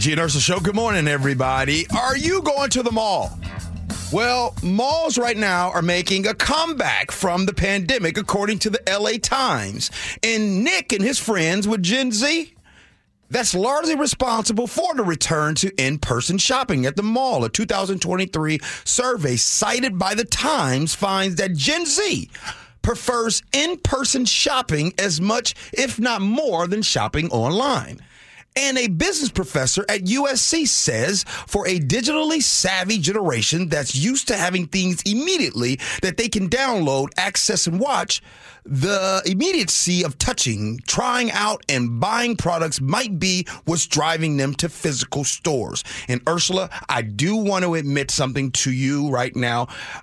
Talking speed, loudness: 150 wpm, -20 LUFS